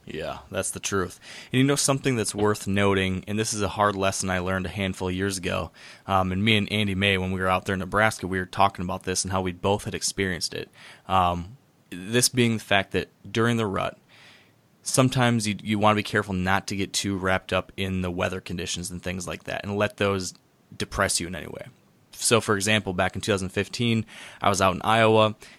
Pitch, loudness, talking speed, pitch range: 100 Hz, -25 LUFS, 235 wpm, 95-110 Hz